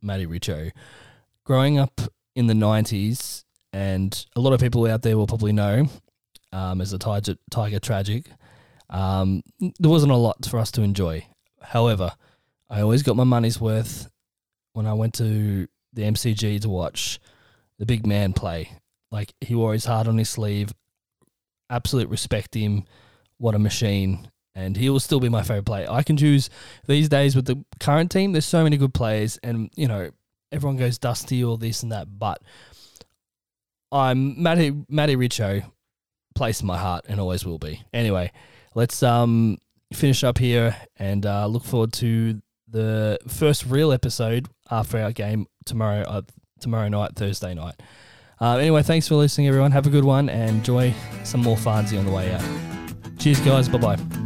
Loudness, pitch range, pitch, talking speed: -22 LUFS, 105-125 Hz, 115 Hz, 175 wpm